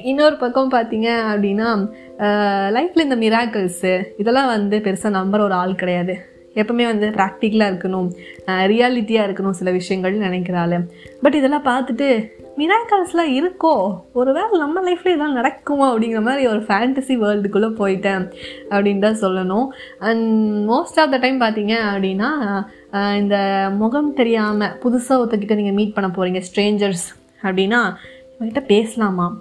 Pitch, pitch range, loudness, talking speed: 215 Hz, 195-255 Hz, -18 LUFS, 130 wpm